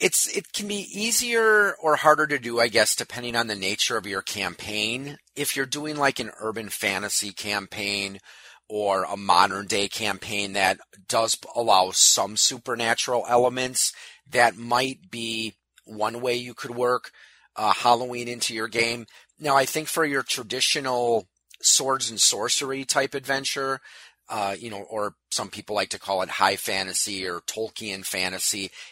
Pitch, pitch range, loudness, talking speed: 120 Hz, 105-135 Hz, -24 LUFS, 160 wpm